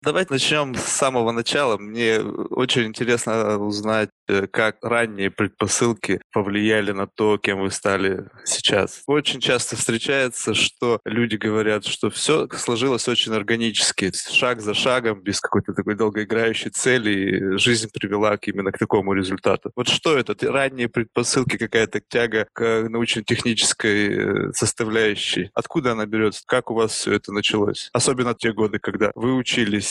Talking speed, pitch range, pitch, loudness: 145 wpm, 105-120 Hz, 110 Hz, -21 LUFS